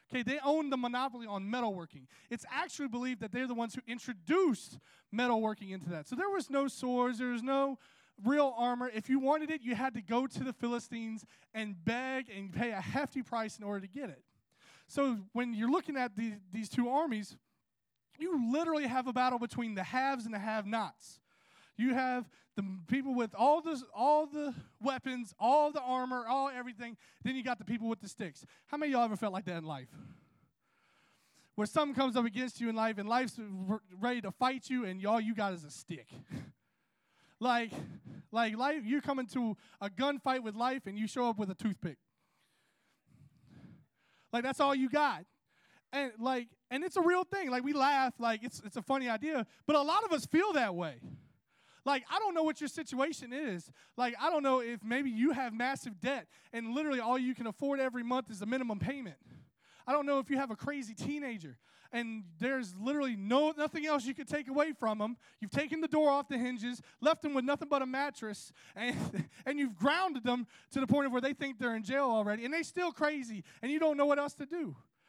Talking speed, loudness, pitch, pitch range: 210 wpm, -35 LUFS, 250 Hz, 225-280 Hz